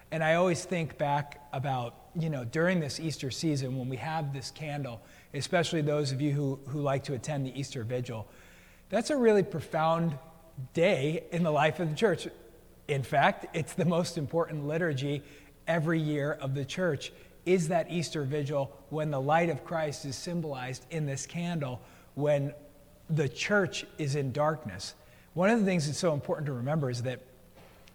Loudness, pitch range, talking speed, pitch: -31 LUFS, 135-165 Hz, 180 wpm, 150 Hz